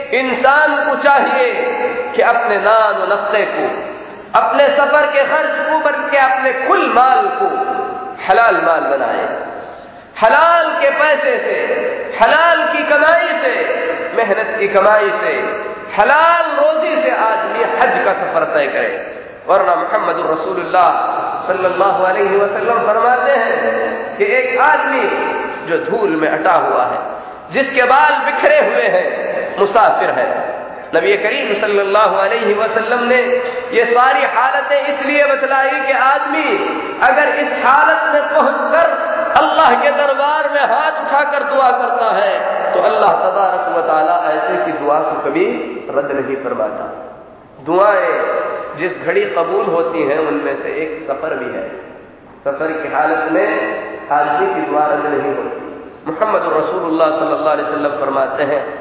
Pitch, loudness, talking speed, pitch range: 280 Hz, -14 LUFS, 130 wpm, 220-330 Hz